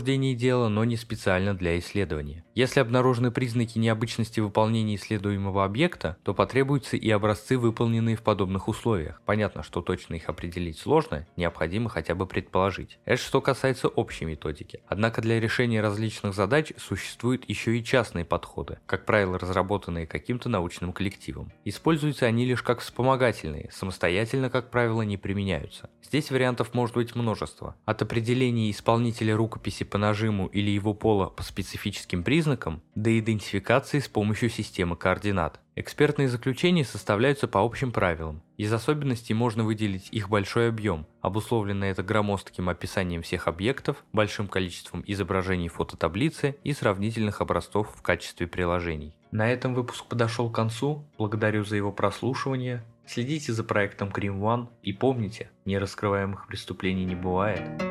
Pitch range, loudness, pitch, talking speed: 95-120 Hz, -27 LUFS, 110 Hz, 140 wpm